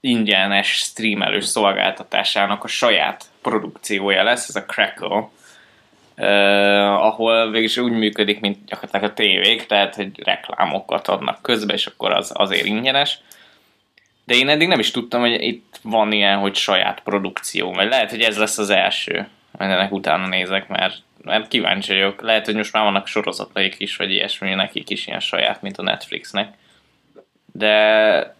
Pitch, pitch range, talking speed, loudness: 105 Hz, 100-115 Hz, 155 wpm, -18 LUFS